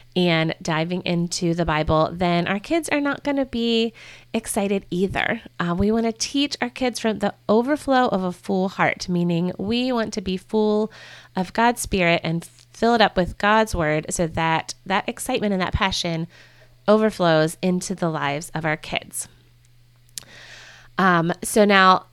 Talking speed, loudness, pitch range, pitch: 165 wpm, -22 LUFS, 165-220 Hz, 185 Hz